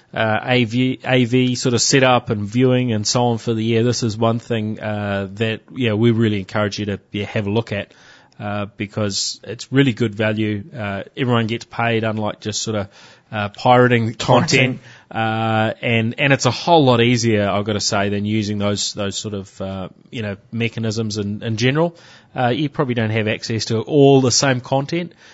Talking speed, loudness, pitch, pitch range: 200 wpm, -18 LUFS, 115 Hz, 105-125 Hz